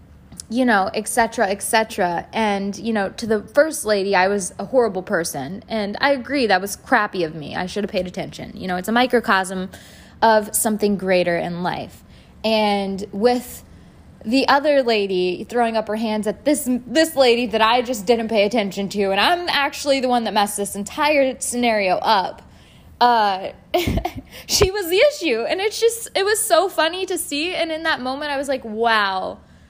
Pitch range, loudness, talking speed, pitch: 200-270 Hz, -19 LUFS, 190 wpm, 225 Hz